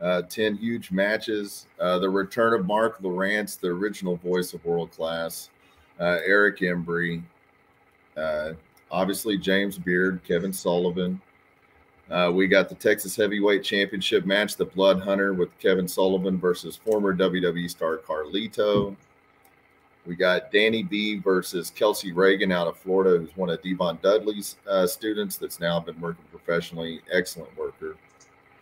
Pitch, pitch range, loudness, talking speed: 95 Hz, 90-100 Hz, -25 LUFS, 145 wpm